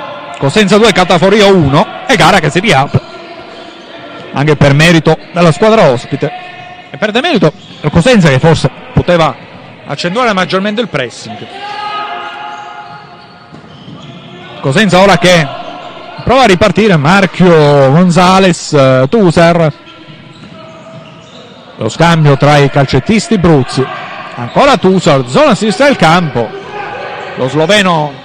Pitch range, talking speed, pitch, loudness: 145-200 Hz, 105 wpm, 170 Hz, -8 LUFS